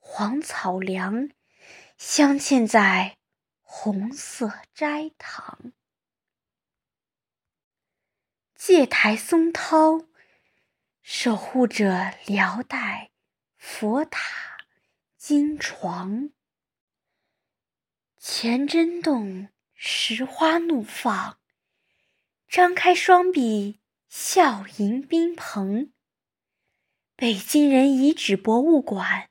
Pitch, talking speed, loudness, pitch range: 260 Hz, 95 characters per minute, -22 LUFS, 210-320 Hz